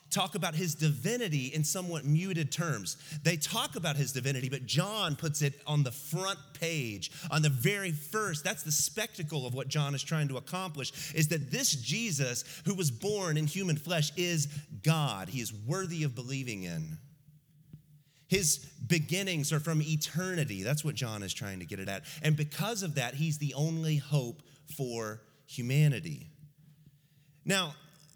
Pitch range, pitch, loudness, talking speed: 140-165 Hz, 150 Hz, -32 LUFS, 165 wpm